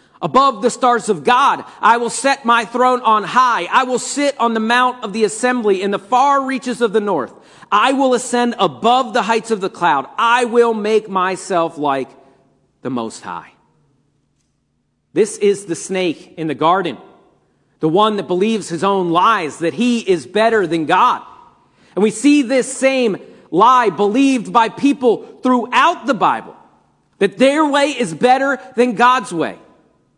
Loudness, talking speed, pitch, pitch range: -15 LUFS, 170 wpm, 230 Hz, 195-255 Hz